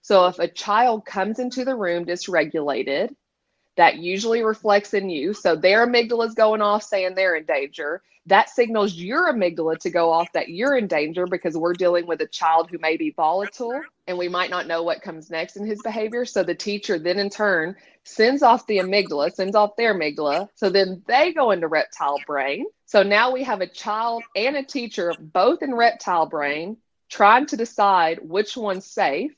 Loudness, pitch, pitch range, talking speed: -21 LUFS, 195 Hz, 175-230 Hz, 195 wpm